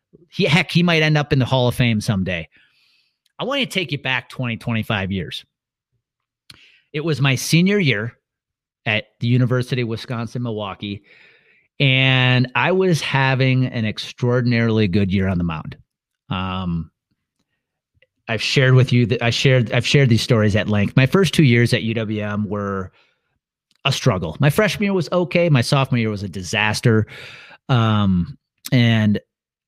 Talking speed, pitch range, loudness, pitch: 160 wpm, 105-140 Hz, -18 LUFS, 125 Hz